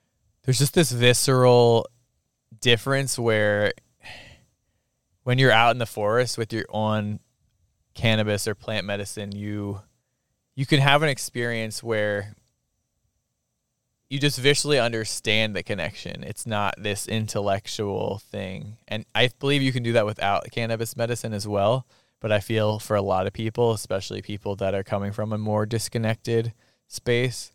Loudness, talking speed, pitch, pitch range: -24 LUFS, 145 wpm, 110 Hz, 105-120 Hz